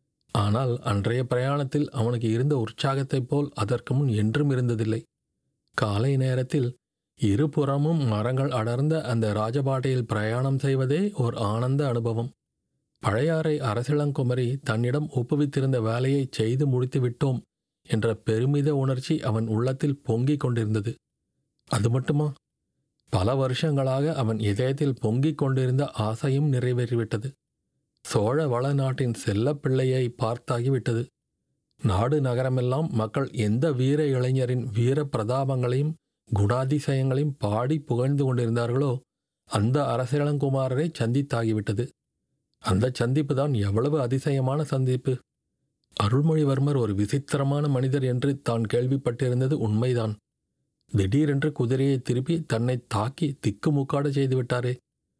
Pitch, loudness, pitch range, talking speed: 130 Hz, -26 LUFS, 120-140 Hz, 95 wpm